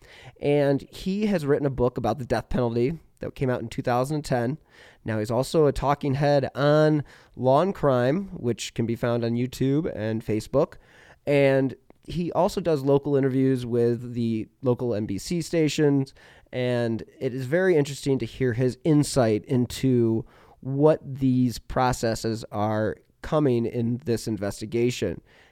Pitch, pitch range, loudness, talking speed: 130 Hz, 120-145 Hz, -25 LUFS, 145 wpm